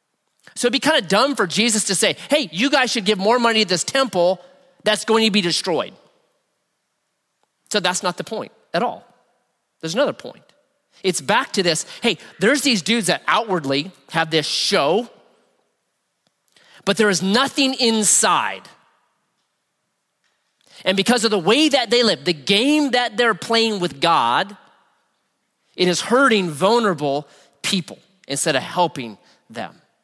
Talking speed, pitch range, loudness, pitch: 155 wpm, 180-240 Hz, -18 LUFS, 210 Hz